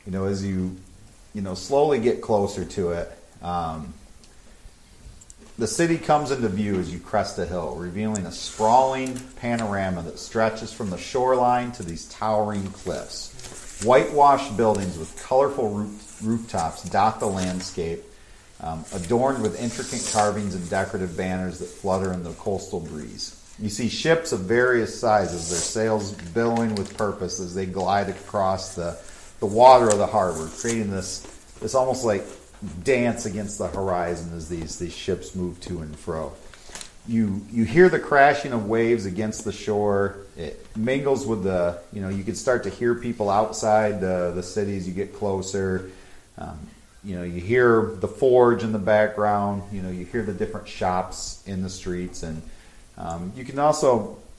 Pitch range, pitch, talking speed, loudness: 90-115 Hz, 100 Hz, 165 wpm, -24 LUFS